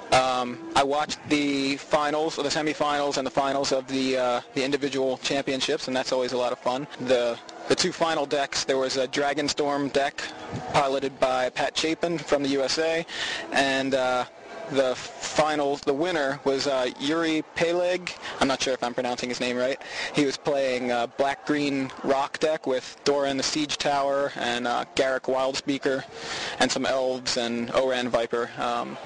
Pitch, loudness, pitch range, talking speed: 135 Hz, -26 LUFS, 130-145 Hz, 175 wpm